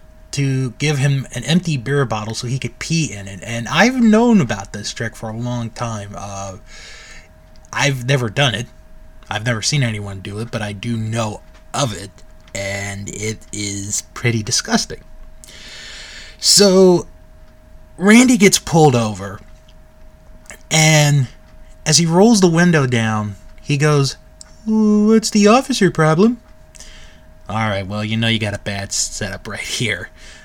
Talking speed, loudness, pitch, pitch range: 150 wpm, -16 LUFS, 115 Hz, 100-145 Hz